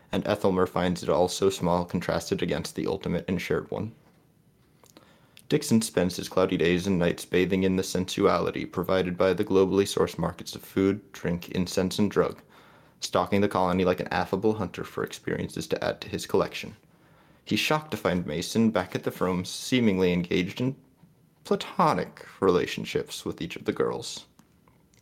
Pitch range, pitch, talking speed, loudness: 90-105 Hz, 95 Hz, 170 wpm, -27 LUFS